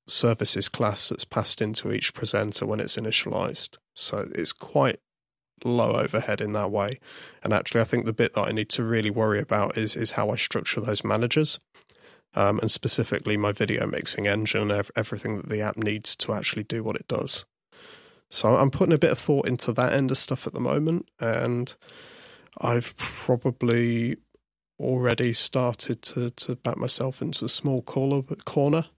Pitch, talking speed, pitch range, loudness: 120 Hz, 180 wpm, 110-130 Hz, -25 LUFS